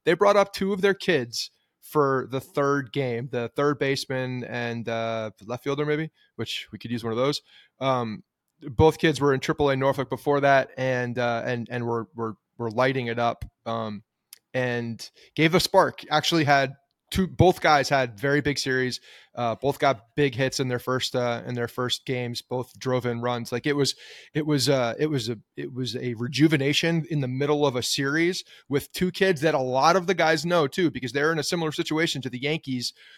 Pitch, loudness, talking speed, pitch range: 135 Hz, -25 LUFS, 205 wpm, 120-150 Hz